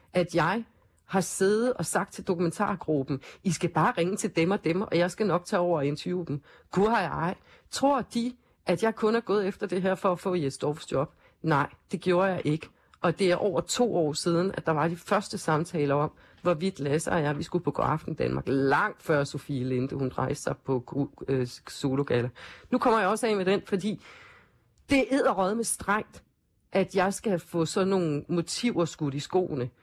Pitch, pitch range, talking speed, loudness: 175 Hz, 150-200 Hz, 215 wpm, -28 LUFS